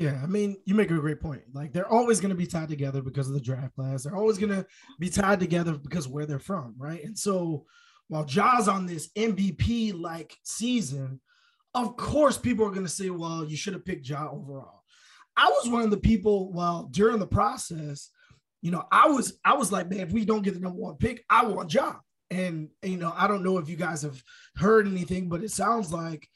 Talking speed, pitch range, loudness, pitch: 230 wpm, 155-210 Hz, -27 LUFS, 185 Hz